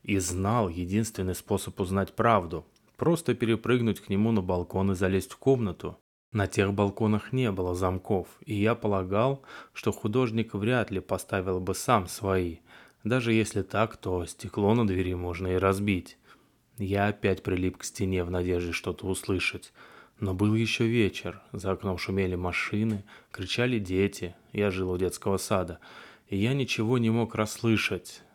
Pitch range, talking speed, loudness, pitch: 95-115 Hz, 155 wpm, -28 LUFS, 100 Hz